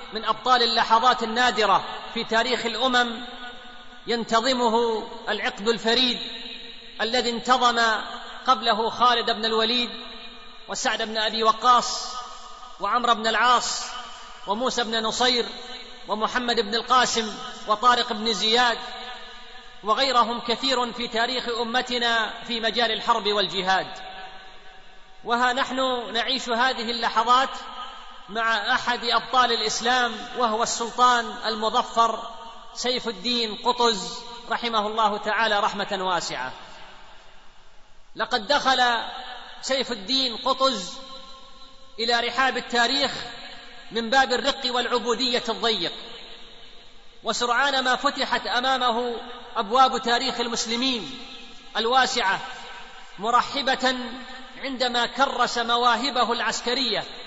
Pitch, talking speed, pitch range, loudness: 240 Hz, 90 wpm, 230-250 Hz, -23 LUFS